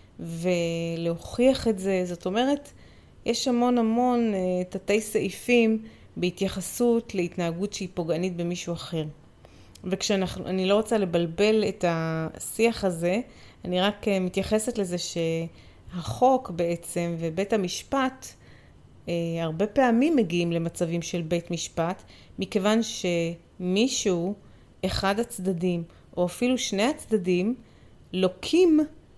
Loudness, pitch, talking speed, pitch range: -26 LUFS, 190 Hz, 105 wpm, 170-220 Hz